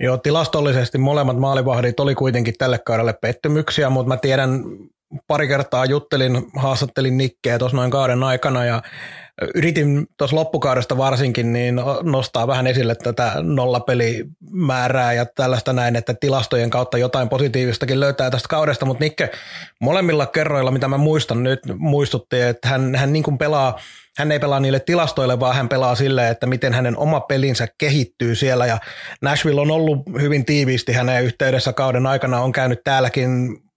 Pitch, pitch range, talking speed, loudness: 130 Hz, 125-145 Hz, 155 wpm, -18 LUFS